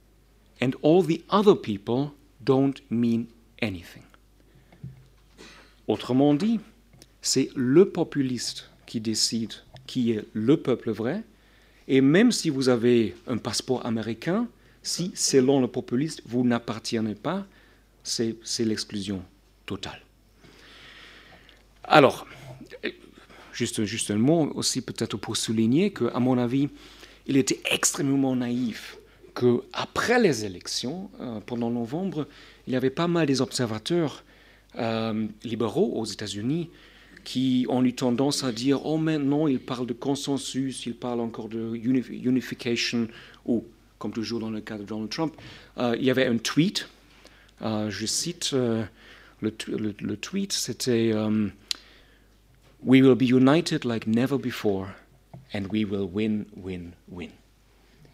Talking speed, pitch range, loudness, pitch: 130 wpm, 110-135 Hz, -26 LUFS, 120 Hz